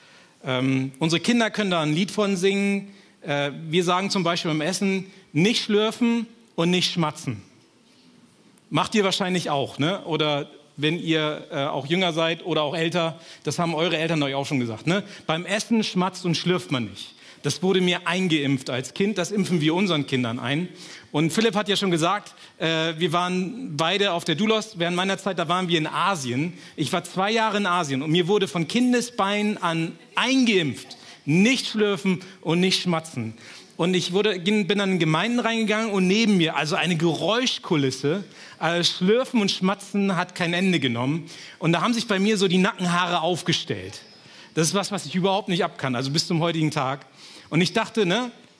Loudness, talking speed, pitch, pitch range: -23 LUFS, 190 wpm, 175 Hz, 155-200 Hz